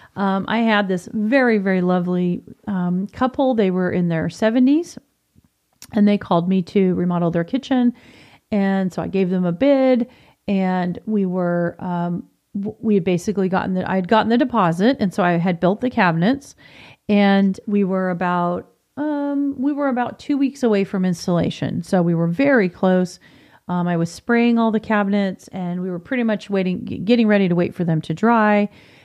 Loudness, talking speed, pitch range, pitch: -19 LUFS, 185 wpm, 180-230 Hz, 195 Hz